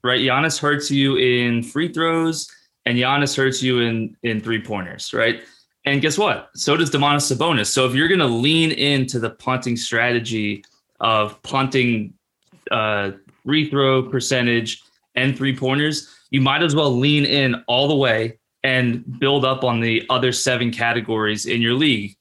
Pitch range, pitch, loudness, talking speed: 115-140 Hz, 130 Hz, -19 LUFS, 170 wpm